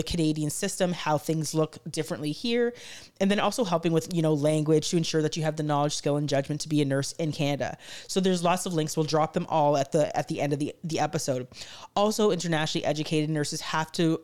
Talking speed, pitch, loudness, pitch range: 235 wpm, 155 Hz, -27 LUFS, 150-170 Hz